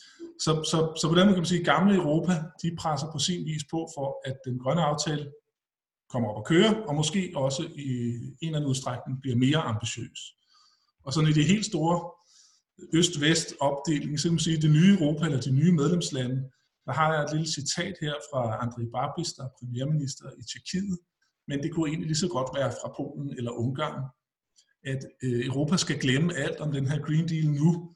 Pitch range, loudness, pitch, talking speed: 135-170 Hz, -27 LUFS, 155 Hz, 200 wpm